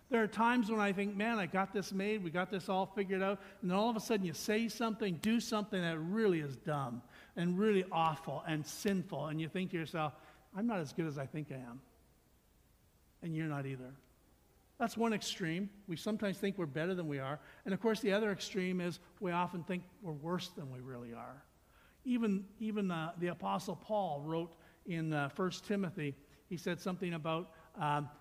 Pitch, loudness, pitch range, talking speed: 180 Hz, -38 LUFS, 155-200 Hz, 210 wpm